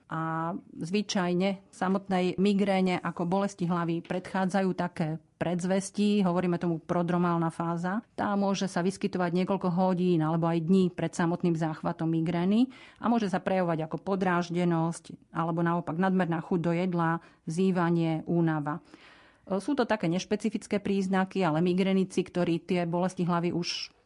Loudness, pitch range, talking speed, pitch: -29 LUFS, 170-195 Hz, 135 wpm, 180 Hz